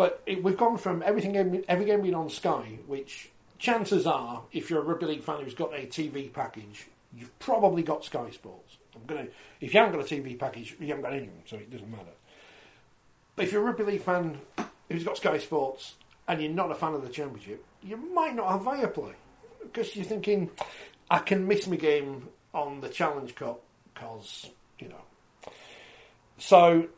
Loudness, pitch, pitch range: -29 LUFS, 170 Hz, 140-200 Hz